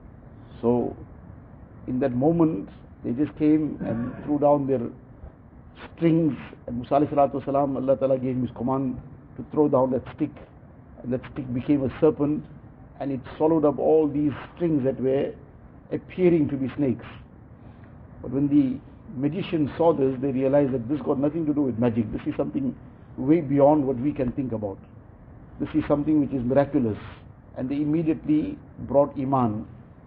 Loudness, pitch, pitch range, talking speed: -24 LUFS, 135 Hz, 125-150 Hz, 160 wpm